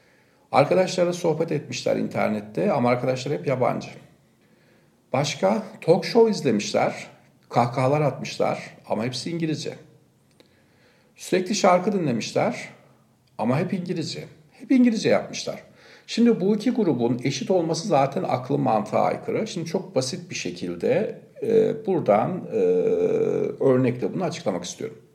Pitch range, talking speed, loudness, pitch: 150-235 Hz, 110 wpm, -23 LUFS, 180 Hz